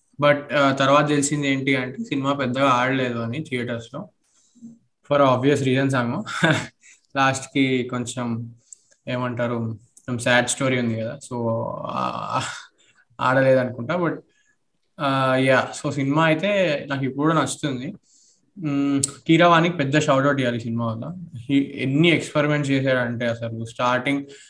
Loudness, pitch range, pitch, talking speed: -21 LUFS, 125-145 Hz, 135 Hz, 110 wpm